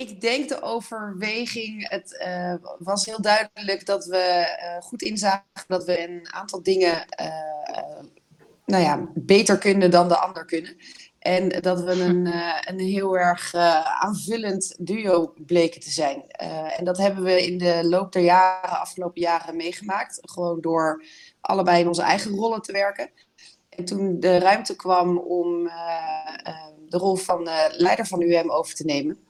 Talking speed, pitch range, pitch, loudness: 170 wpm, 170-195 Hz, 180 Hz, -23 LUFS